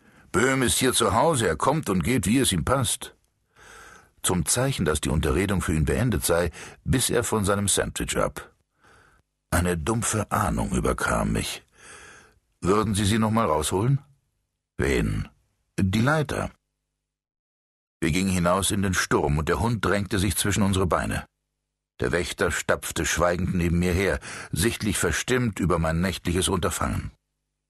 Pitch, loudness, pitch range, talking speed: 95 Hz, -24 LUFS, 85-110 Hz, 150 wpm